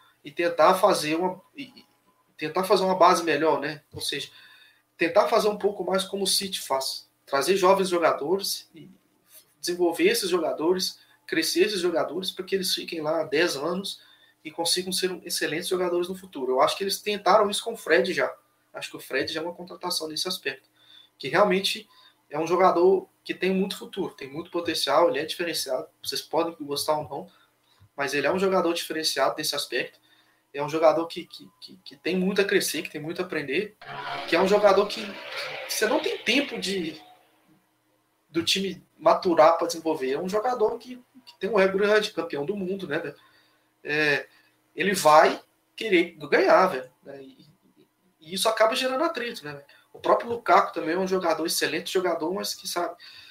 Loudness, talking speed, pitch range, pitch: -25 LUFS, 185 wpm, 160-205 Hz, 185 Hz